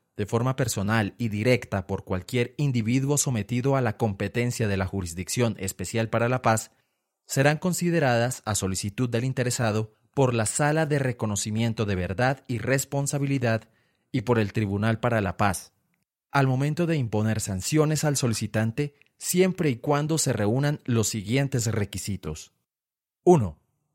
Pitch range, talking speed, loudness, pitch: 110-135 Hz, 145 wpm, -26 LUFS, 115 Hz